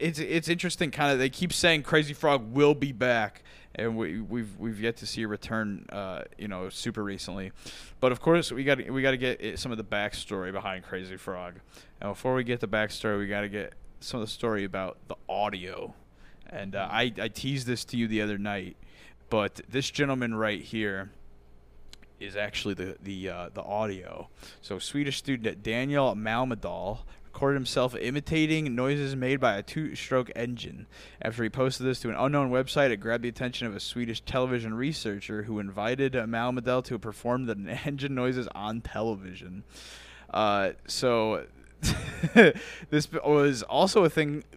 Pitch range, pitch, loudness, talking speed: 105-135 Hz, 115 Hz, -29 LUFS, 180 wpm